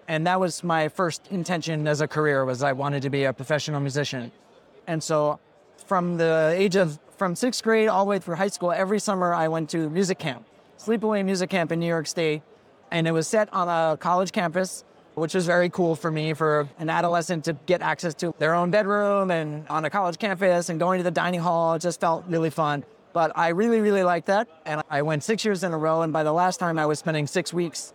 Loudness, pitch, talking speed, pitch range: -24 LUFS, 170 Hz, 235 wpm, 155-185 Hz